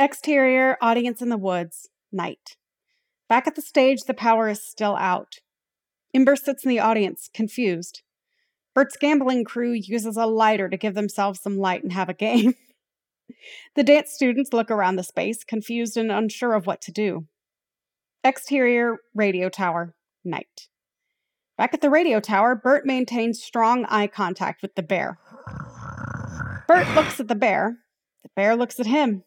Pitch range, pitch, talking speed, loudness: 210-265 Hz, 235 Hz, 160 wpm, -22 LUFS